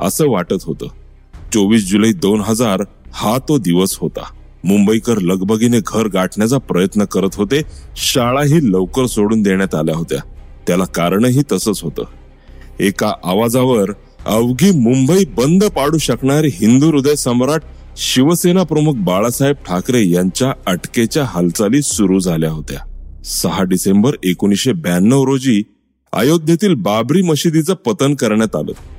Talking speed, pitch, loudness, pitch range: 120 wpm, 110 Hz, -14 LUFS, 95-140 Hz